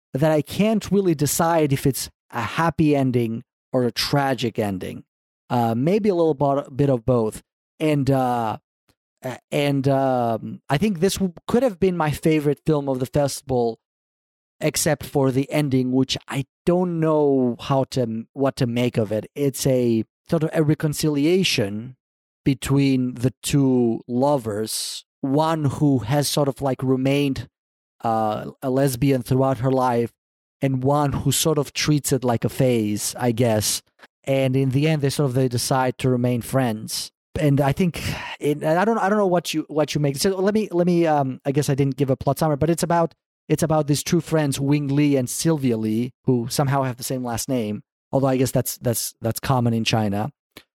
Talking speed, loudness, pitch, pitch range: 185 wpm, -21 LUFS, 135 Hz, 125-150 Hz